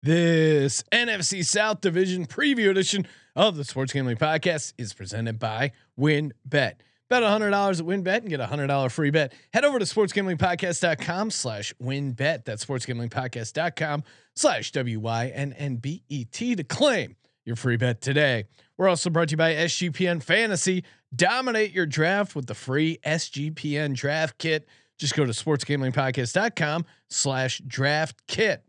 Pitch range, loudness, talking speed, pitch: 130-180 Hz, -25 LUFS, 170 wpm, 150 Hz